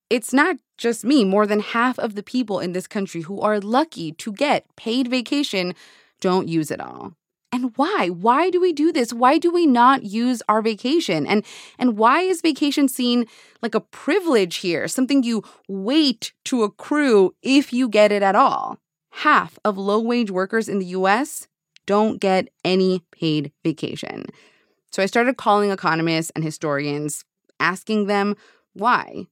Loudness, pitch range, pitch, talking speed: -20 LUFS, 190-260 Hz, 220 Hz, 170 wpm